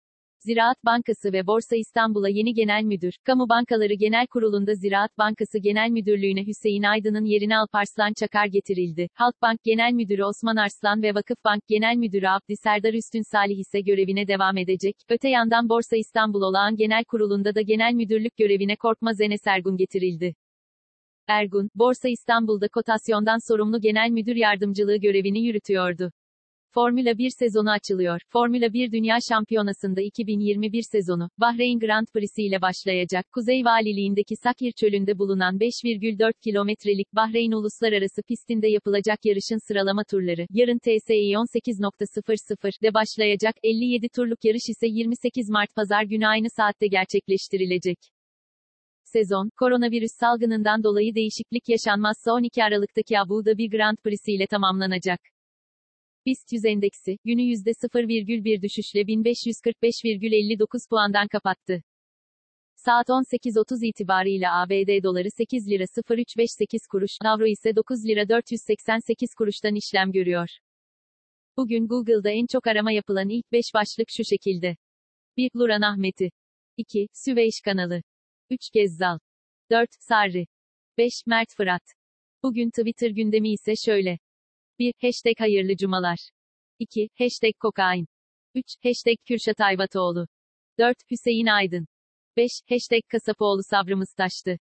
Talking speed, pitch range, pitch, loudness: 125 wpm, 200-230 Hz, 215 Hz, -23 LUFS